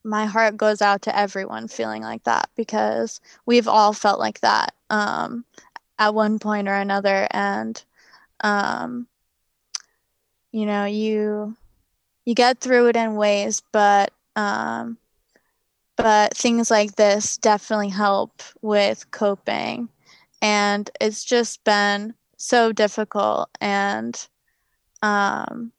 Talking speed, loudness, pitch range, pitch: 115 wpm, -21 LUFS, 200-225 Hz, 210 Hz